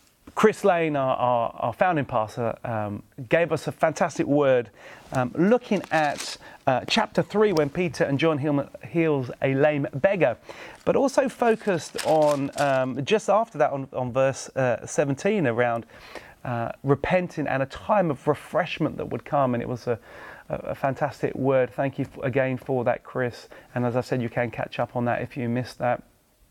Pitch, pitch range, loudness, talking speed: 140 Hz, 125-165 Hz, -25 LUFS, 180 wpm